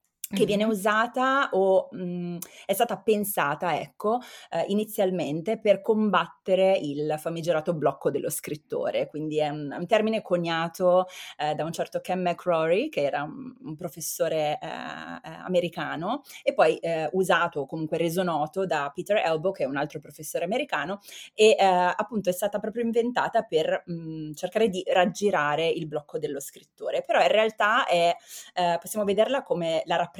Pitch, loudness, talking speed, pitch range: 180 Hz, -26 LUFS, 160 wpm, 165-210 Hz